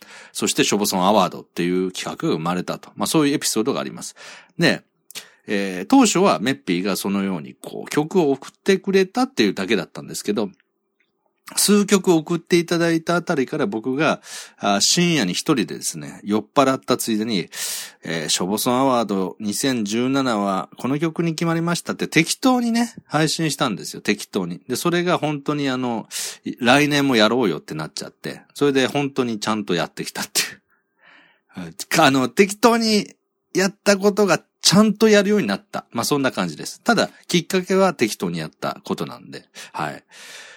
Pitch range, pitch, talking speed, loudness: 125-190 Hz, 155 Hz, 365 characters per minute, -20 LUFS